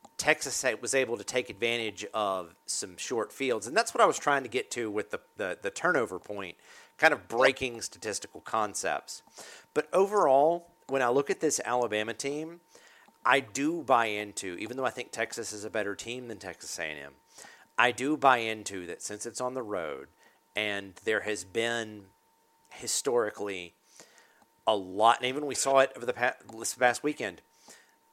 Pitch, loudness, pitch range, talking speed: 120 Hz, -30 LUFS, 105-155 Hz, 175 wpm